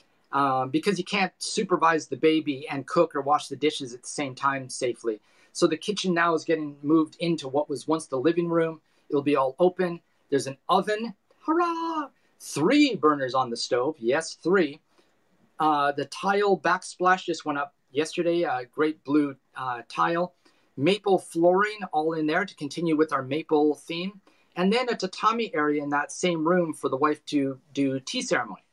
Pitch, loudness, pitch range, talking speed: 160 Hz, -26 LUFS, 145-180 Hz, 180 wpm